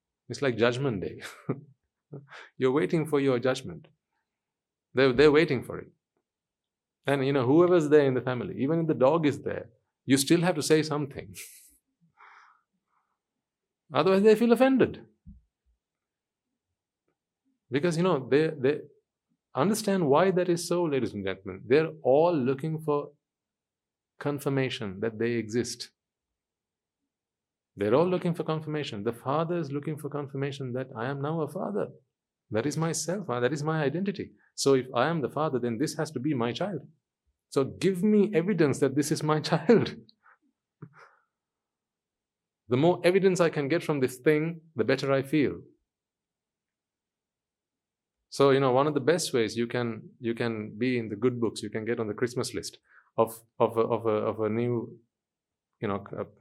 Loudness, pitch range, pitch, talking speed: -27 LUFS, 120-160 Hz, 140 Hz, 165 wpm